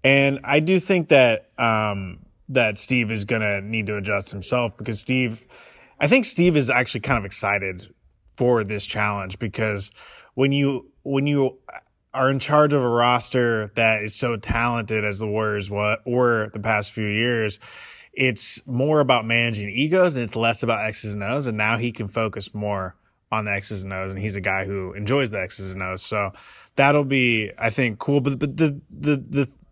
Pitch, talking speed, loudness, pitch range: 115 Hz, 190 wpm, -22 LUFS, 105-135 Hz